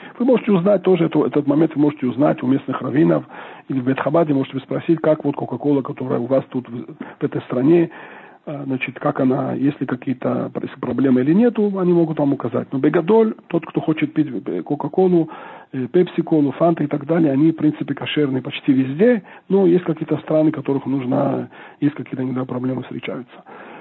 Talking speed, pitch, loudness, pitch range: 175 wpm, 145 Hz, -19 LUFS, 135-165 Hz